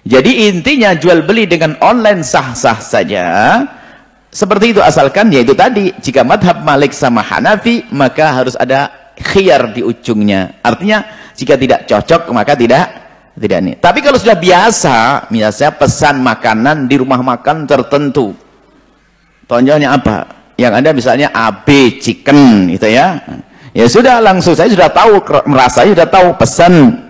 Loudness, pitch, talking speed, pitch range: -9 LUFS, 160 Hz, 135 wpm, 135-215 Hz